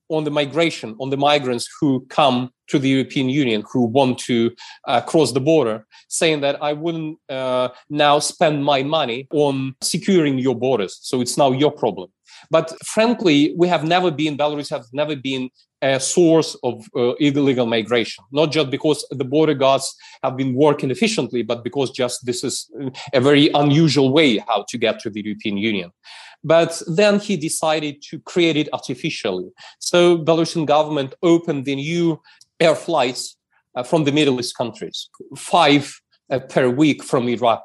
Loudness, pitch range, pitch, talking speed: -19 LUFS, 130-160 Hz, 145 Hz, 170 wpm